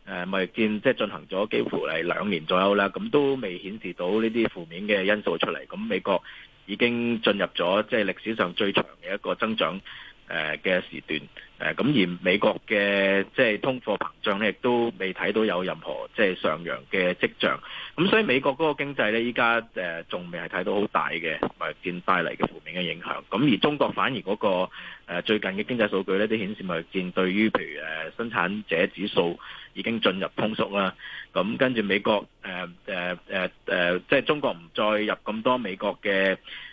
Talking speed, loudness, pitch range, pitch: 285 characters per minute, -26 LUFS, 95-115 Hz, 100 Hz